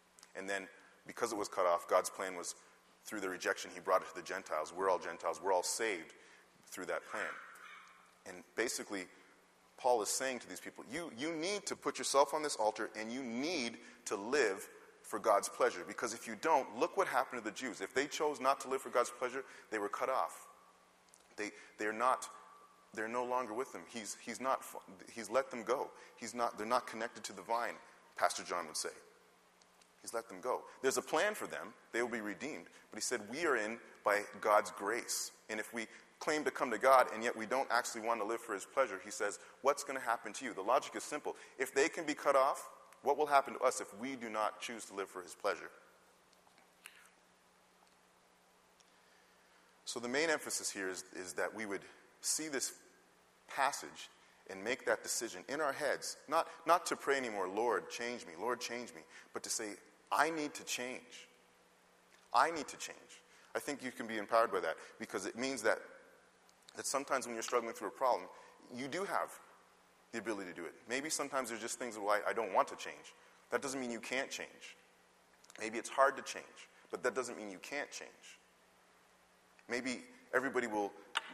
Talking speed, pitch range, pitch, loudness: 205 wpm, 100-135 Hz, 120 Hz, -38 LUFS